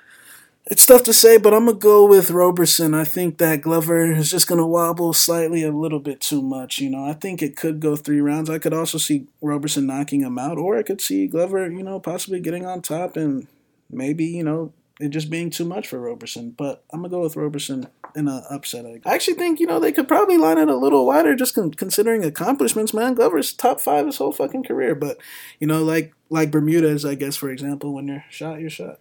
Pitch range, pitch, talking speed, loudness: 145-180 Hz, 160 Hz, 230 wpm, -18 LUFS